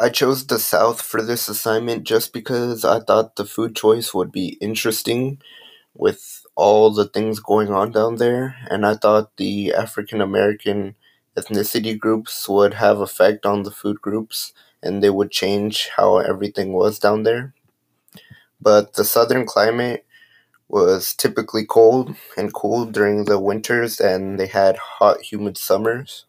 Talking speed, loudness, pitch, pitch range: 155 wpm, -19 LUFS, 110 Hz, 100-115 Hz